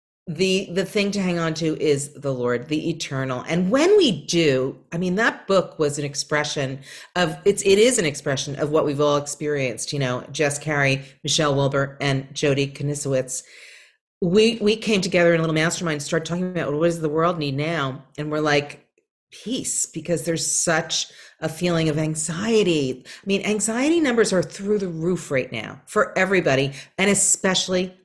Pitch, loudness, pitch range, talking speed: 160 Hz, -22 LUFS, 145-185 Hz, 185 wpm